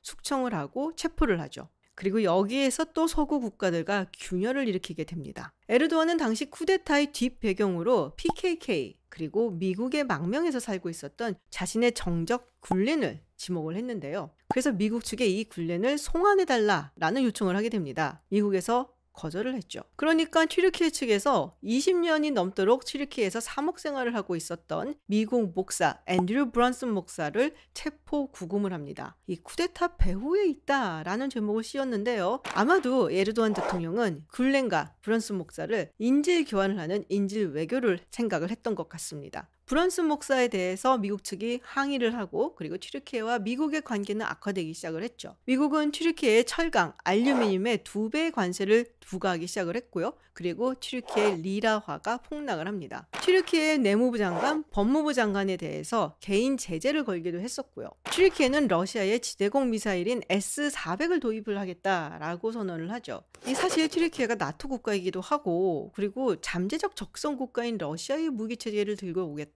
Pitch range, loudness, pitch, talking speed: 190-275 Hz, -28 LUFS, 225 Hz, 365 characters per minute